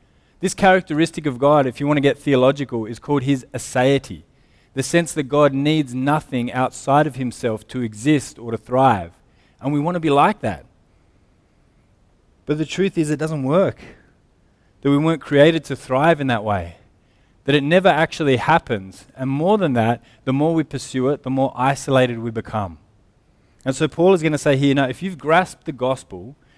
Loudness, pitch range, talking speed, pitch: -19 LUFS, 125-150 Hz, 190 wpm, 135 Hz